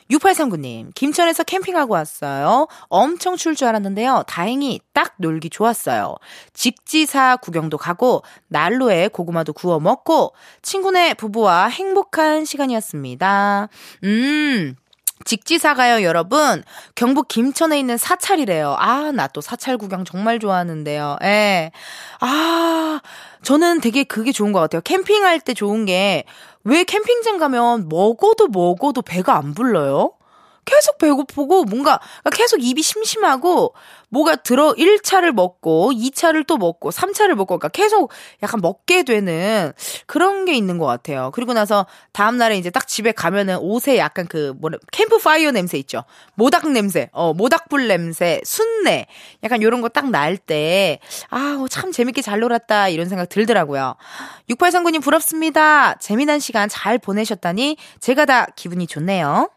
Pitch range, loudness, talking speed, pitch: 195-315 Hz, -17 LUFS, 300 characters per minute, 245 Hz